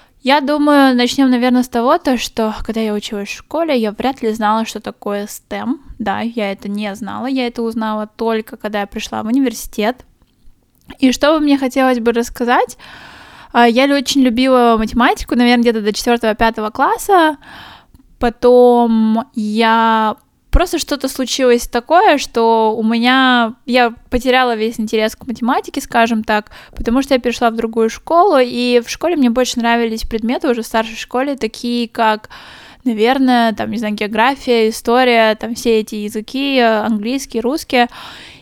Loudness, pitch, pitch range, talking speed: -15 LUFS, 240 Hz, 225-260 Hz, 155 wpm